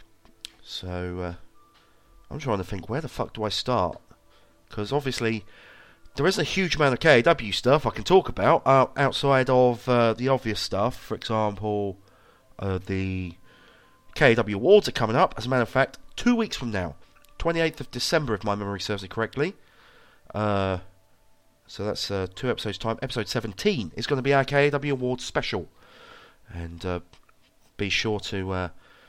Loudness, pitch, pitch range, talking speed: -25 LUFS, 115 Hz, 100-135 Hz, 170 wpm